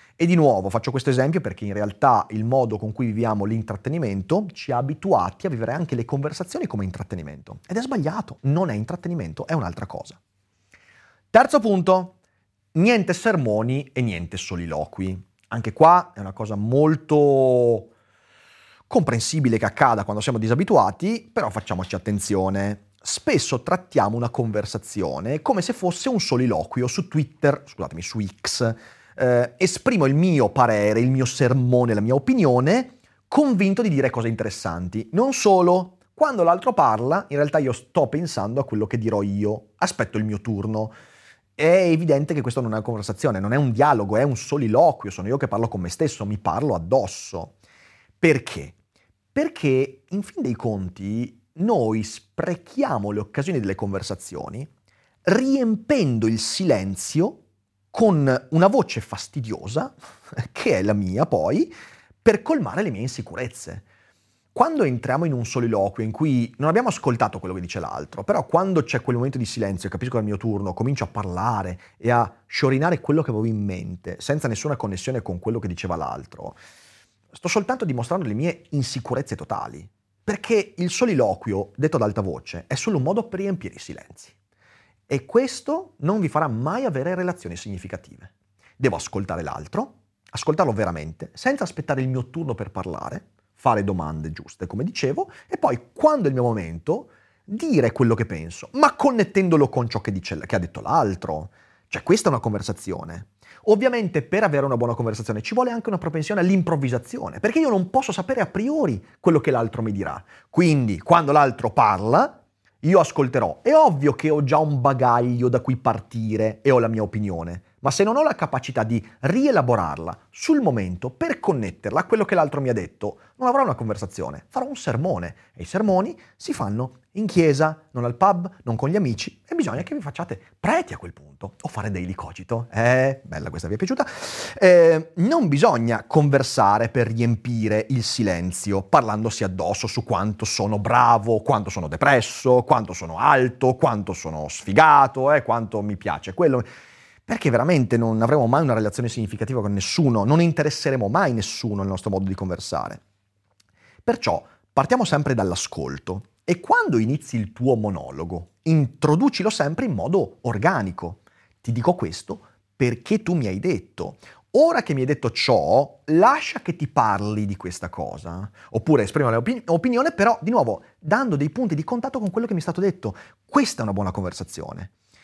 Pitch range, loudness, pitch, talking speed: 105-160 Hz, -22 LUFS, 120 Hz, 170 wpm